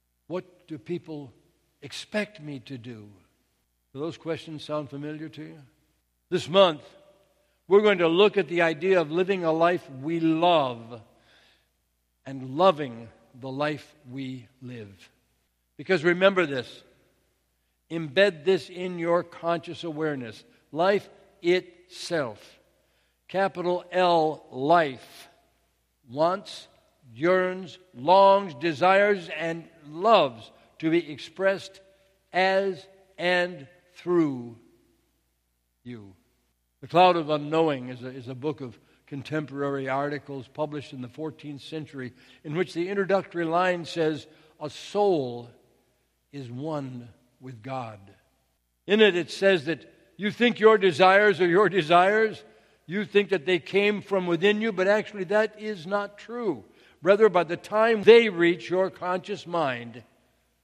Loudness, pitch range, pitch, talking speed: -24 LUFS, 130-185 Hz, 160 Hz, 125 wpm